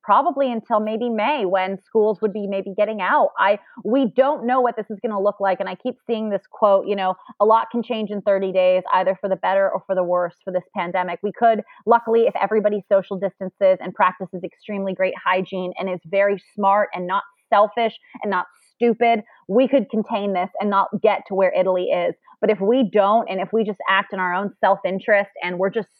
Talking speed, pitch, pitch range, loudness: 225 wpm, 200 Hz, 190-225 Hz, -20 LUFS